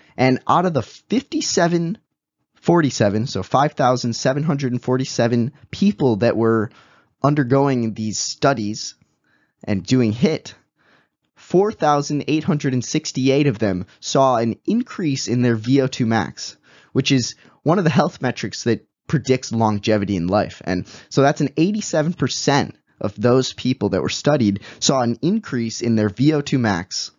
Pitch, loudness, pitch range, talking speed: 130 Hz, -19 LUFS, 115-150 Hz, 125 wpm